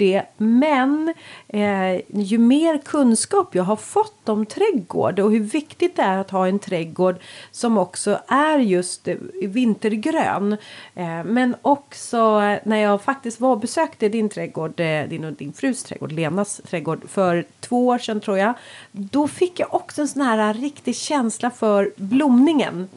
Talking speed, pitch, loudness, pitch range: 160 wpm, 220 Hz, -20 LUFS, 195-275 Hz